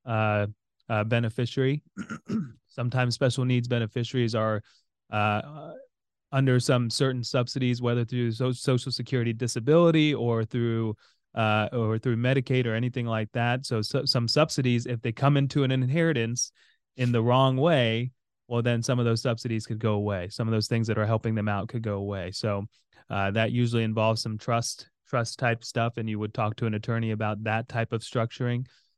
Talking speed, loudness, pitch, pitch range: 180 wpm, -27 LUFS, 120 Hz, 110-125 Hz